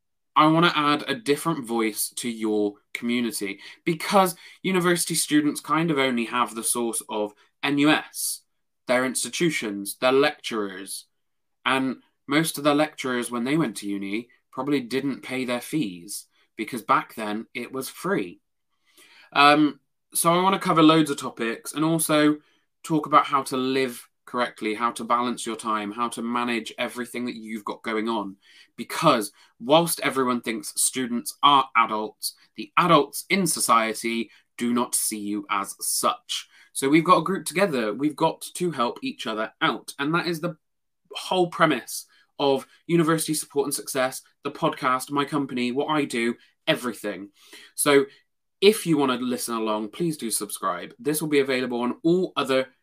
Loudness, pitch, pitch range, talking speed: -24 LUFS, 130 Hz, 115-155 Hz, 160 wpm